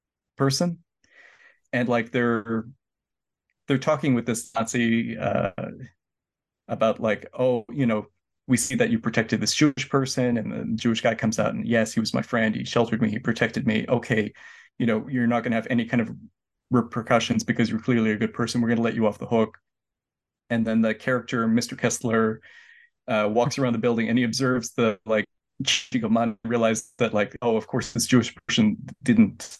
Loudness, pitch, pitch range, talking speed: -24 LUFS, 115 Hz, 110-125 Hz, 190 wpm